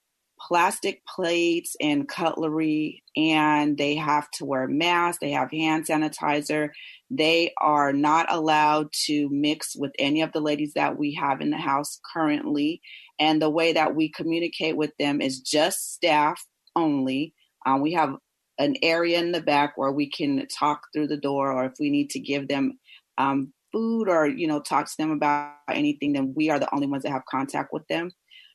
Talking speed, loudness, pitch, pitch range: 185 wpm, -24 LUFS, 150 Hz, 145-165 Hz